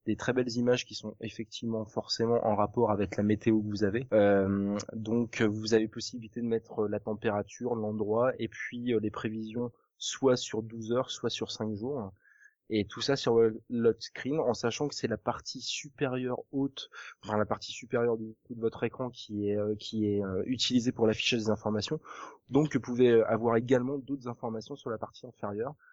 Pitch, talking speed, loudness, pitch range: 115 Hz, 185 wpm, -31 LUFS, 110-125 Hz